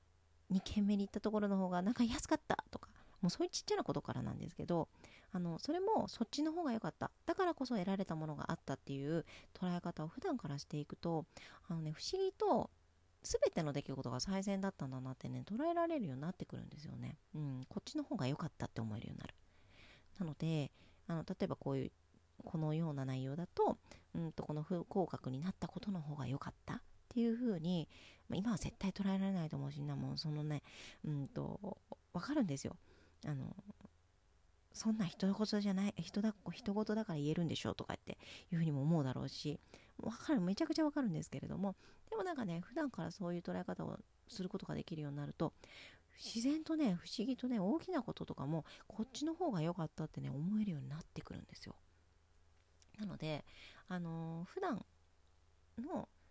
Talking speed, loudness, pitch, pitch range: 410 characters per minute, -42 LUFS, 170 Hz, 140-210 Hz